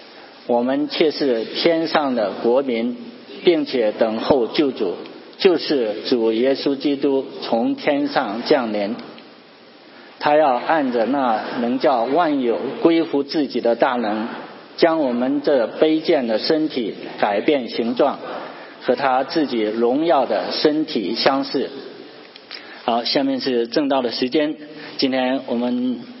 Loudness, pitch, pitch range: -19 LUFS, 145 Hz, 130-160 Hz